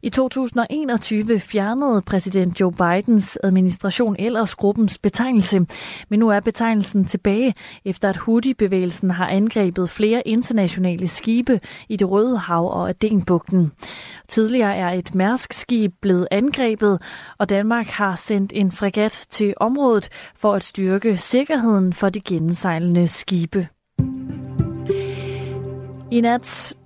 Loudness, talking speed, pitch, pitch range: -20 LUFS, 120 wpm, 200 Hz, 180-225 Hz